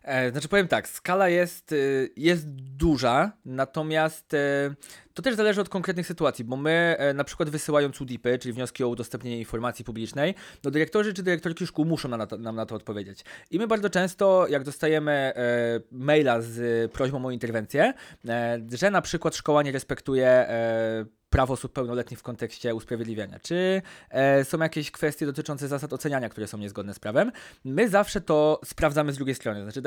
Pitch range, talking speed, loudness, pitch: 120-160 Hz, 165 wpm, -26 LUFS, 140 Hz